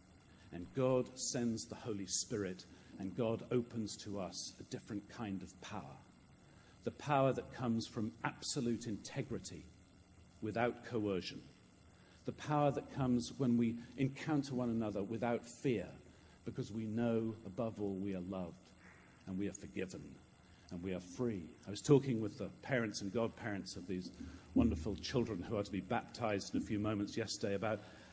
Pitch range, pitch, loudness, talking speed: 95-120 Hz, 105 Hz, -40 LUFS, 160 wpm